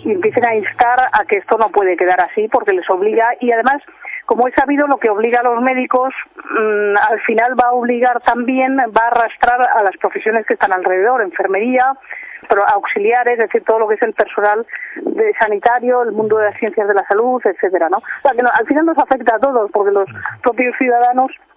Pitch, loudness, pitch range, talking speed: 240 Hz, -14 LUFS, 215-260 Hz, 200 wpm